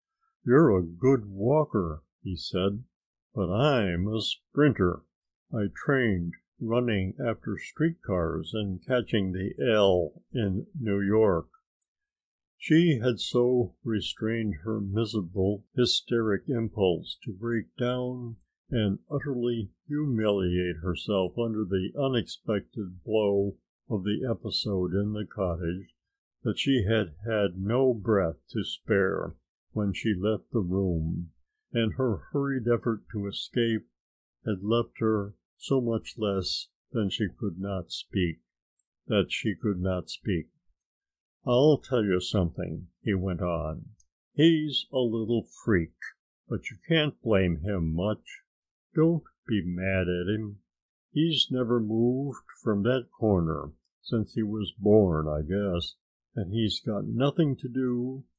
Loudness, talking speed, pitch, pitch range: -28 LUFS, 125 wpm, 105 Hz, 95-120 Hz